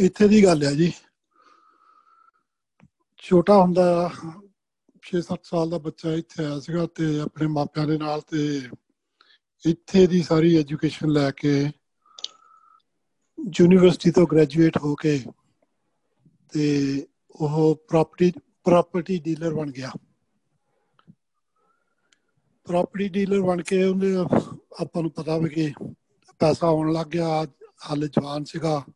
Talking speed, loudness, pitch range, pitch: 110 wpm, -22 LUFS, 155-200 Hz, 170 Hz